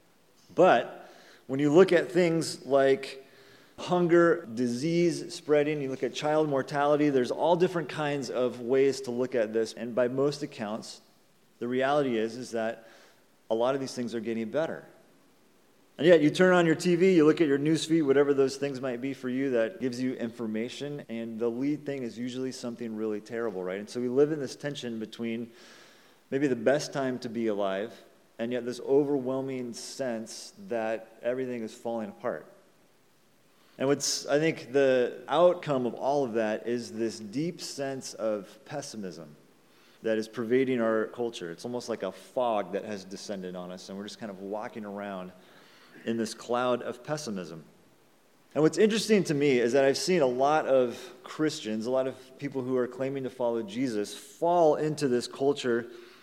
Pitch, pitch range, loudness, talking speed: 130 Hz, 115-145 Hz, -28 LUFS, 180 wpm